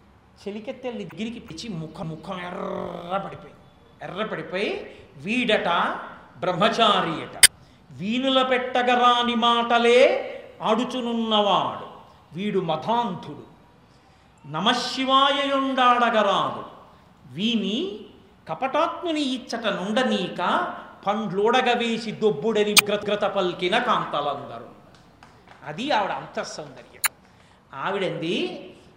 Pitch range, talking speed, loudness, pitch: 195-245 Hz, 60 wpm, -23 LUFS, 215 Hz